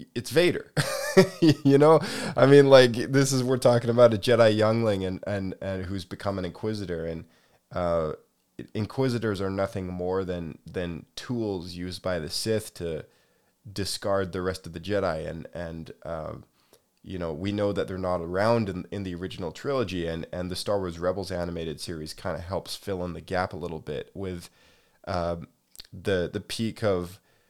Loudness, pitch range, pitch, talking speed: -26 LUFS, 90-110 Hz, 95 Hz, 180 wpm